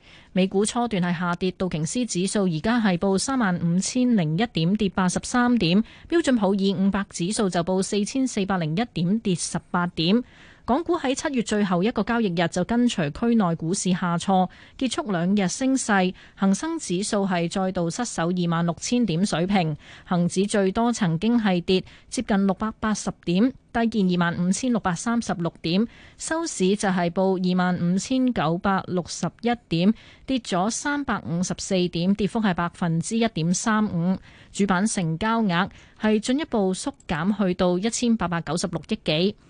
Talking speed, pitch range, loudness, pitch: 265 characters per minute, 180-225 Hz, -24 LUFS, 195 Hz